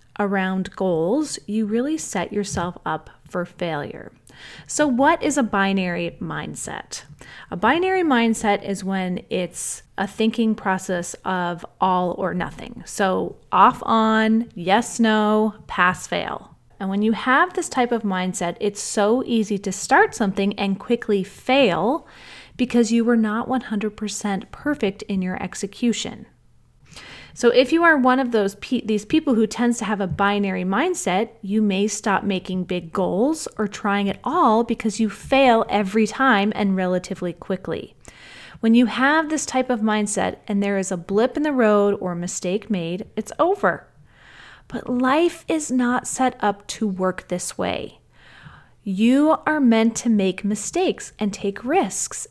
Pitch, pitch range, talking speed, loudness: 215 Hz, 195-245 Hz, 155 wpm, -21 LUFS